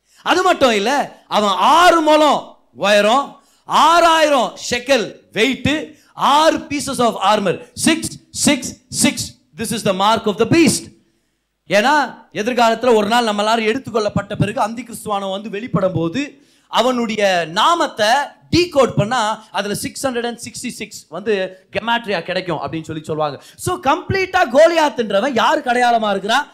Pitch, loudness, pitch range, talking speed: 230 Hz, -16 LUFS, 200-285 Hz, 40 wpm